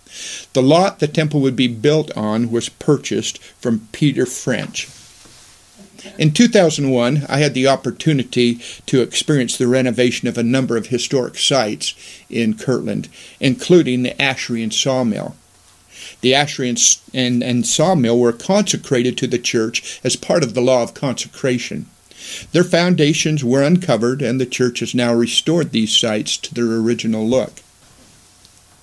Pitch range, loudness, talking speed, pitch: 120-150 Hz, -17 LUFS, 145 wpm, 125 Hz